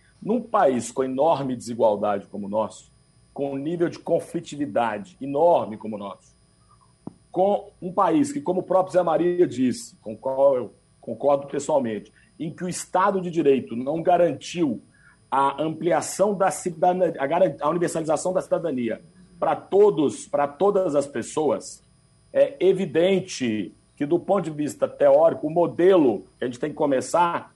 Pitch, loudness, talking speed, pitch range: 170 Hz, -23 LUFS, 155 wpm, 135-185 Hz